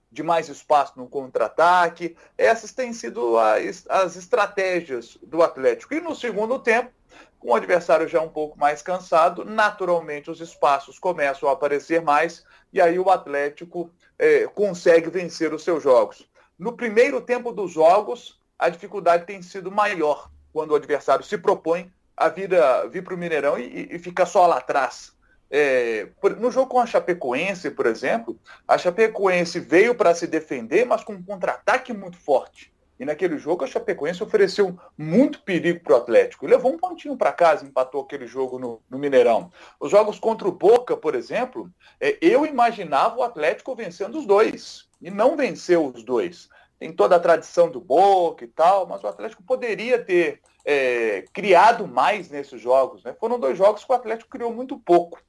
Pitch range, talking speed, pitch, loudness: 165-250 Hz, 170 wpm, 185 Hz, -21 LUFS